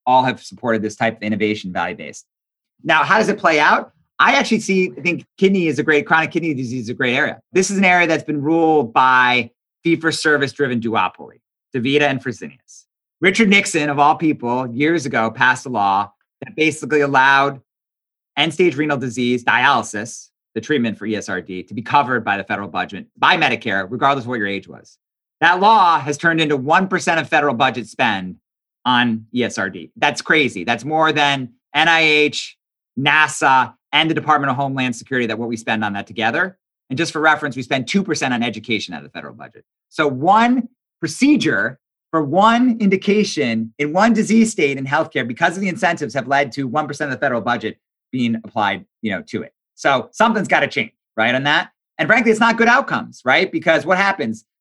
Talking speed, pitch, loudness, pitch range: 195 wpm, 145 Hz, -17 LUFS, 120-165 Hz